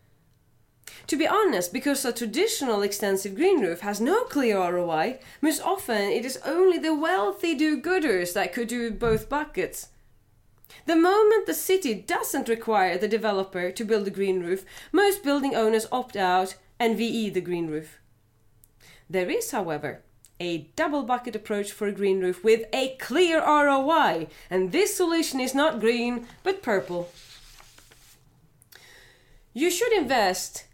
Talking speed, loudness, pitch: 150 wpm, -25 LUFS, 225 Hz